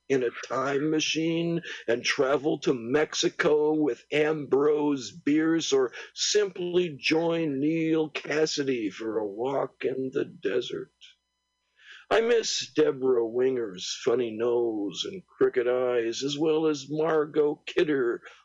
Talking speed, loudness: 115 wpm, -27 LUFS